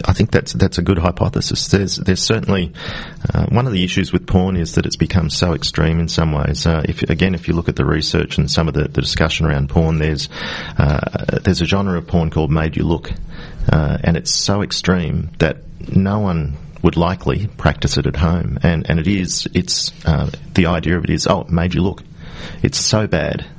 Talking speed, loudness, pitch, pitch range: 210 wpm, -17 LUFS, 85 Hz, 80-95 Hz